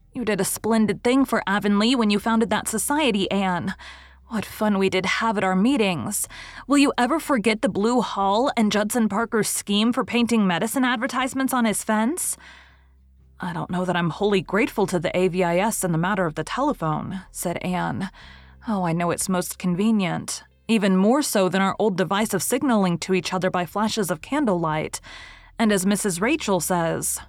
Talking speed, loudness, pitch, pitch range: 185 wpm, -22 LUFS, 205 Hz, 185-230 Hz